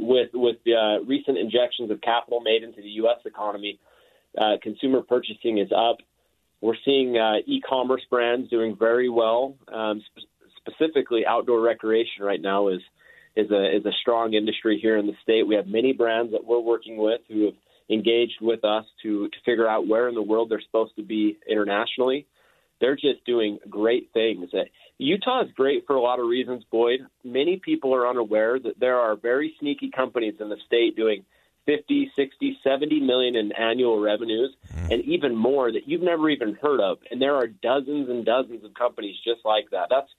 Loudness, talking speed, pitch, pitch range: -24 LUFS, 190 wpm, 115 Hz, 110-130 Hz